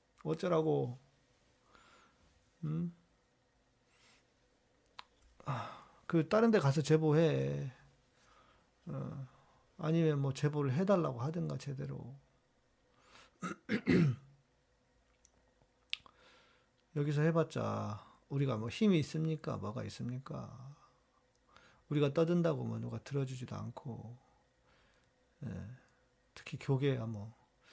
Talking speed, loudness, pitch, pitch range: 170 characters per minute, -36 LUFS, 135 Hz, 125-155 Hz